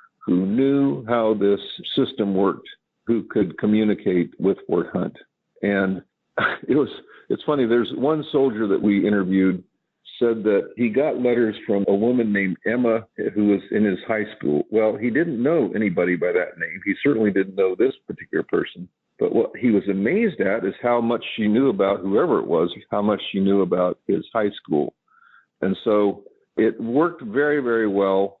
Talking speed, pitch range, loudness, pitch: 175 wpm, 100-120 Hz, -21 LUFS, 110 Hz